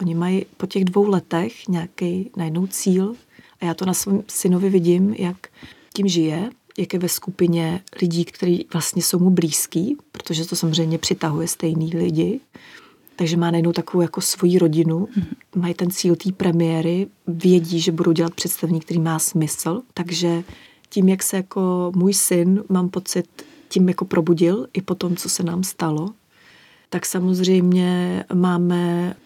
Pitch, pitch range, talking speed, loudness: 180 Hz, 170-190 Hz, 160 wpm, -20 LUFS